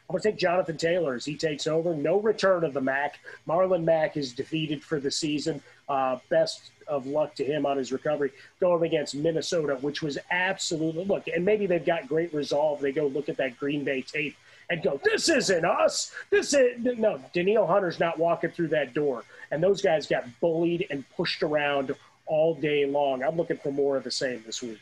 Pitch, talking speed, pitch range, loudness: 160 Hz, 210 wpm, 140-175 Hz, -27 LUFS